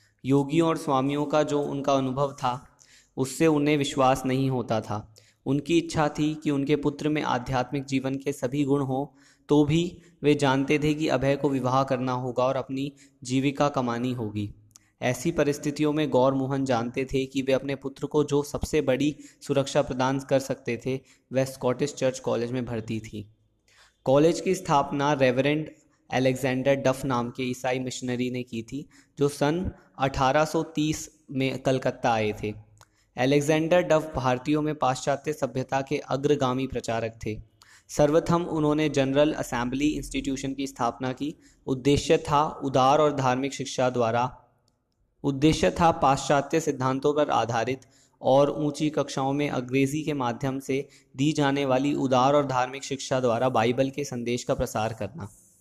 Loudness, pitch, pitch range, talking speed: -26 LUFS, 135 Hz, 125-145 Hz, 155 wpm